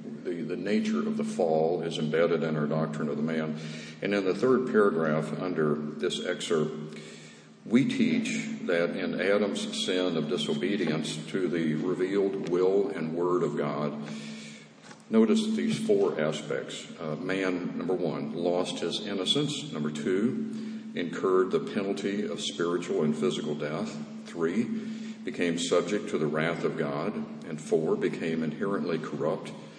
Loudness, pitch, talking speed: -29 LUFS, 95 Hz, 145 wpm